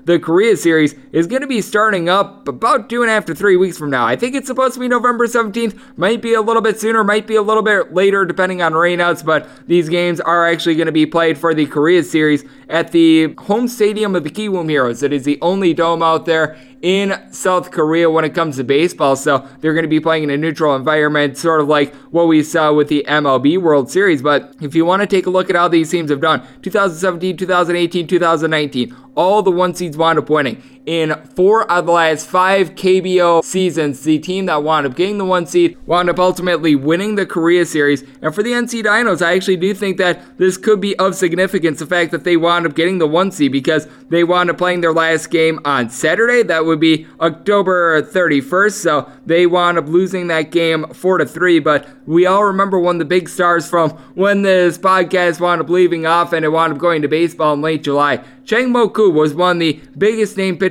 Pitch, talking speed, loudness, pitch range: 170 Hz, 230 wpm, -14 LUFS, 155-185 Hz